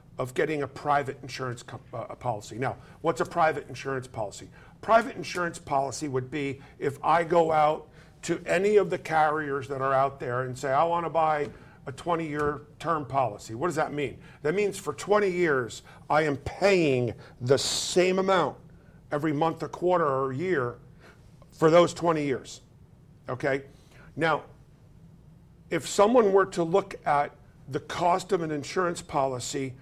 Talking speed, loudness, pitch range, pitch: 160 wpm, -27 LUFS, 135-170 Hz, 150 Hz